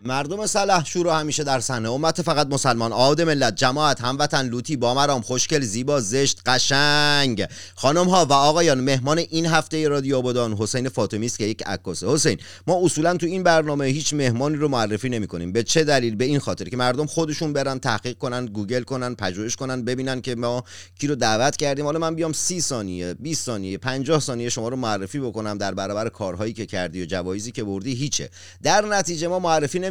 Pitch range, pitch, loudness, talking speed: 115-150 Hz, 130 Hz, -22 LUFS, 200 wpm